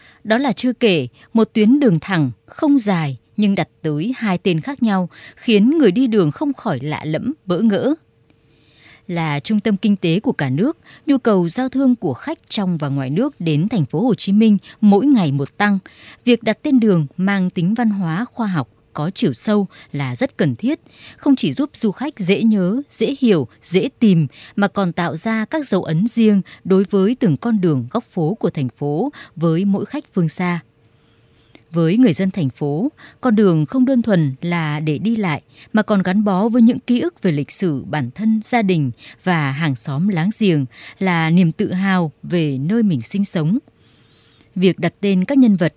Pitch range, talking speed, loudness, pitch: 155-225 Hz, 205 wpm, -18 LUFS, 195 Hz